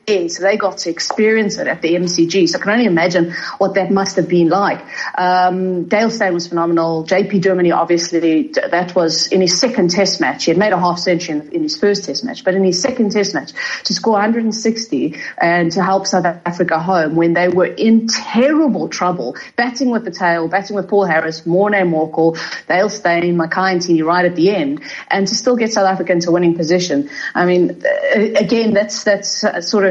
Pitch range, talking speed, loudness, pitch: 175-210 Hz, 205 wpm, -15 LUFS, 190 Hz